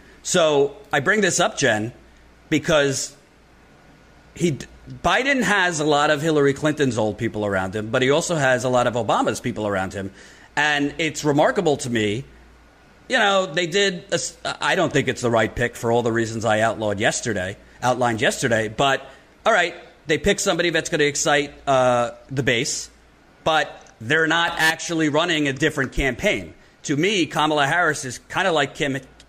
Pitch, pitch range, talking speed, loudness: 145 Hz, 120-160 Hz, 175 wpm, -21 LUFS